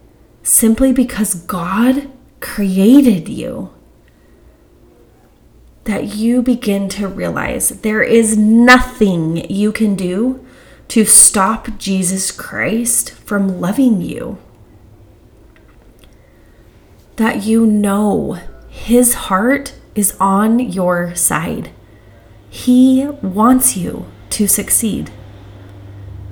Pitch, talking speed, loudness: 200 Hz, 85 wpm, -13 LUFS